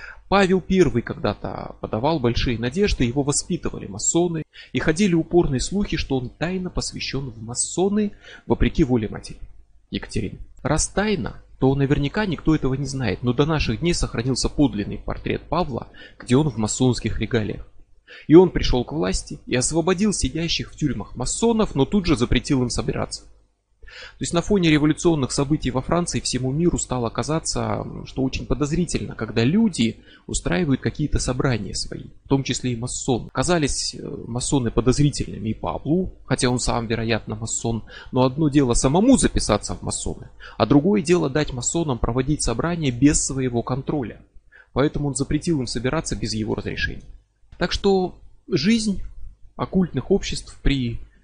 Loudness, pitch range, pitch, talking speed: -22 LUFS, 115-160 Hz, 130 Hz, 150 wpm